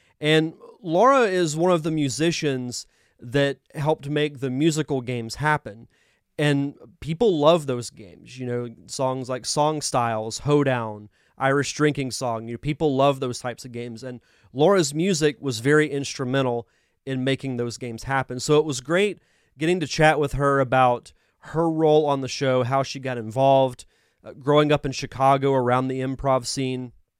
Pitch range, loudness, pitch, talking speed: 125-150 Hz, -23 LUFS, 135 Hz, 165 wpm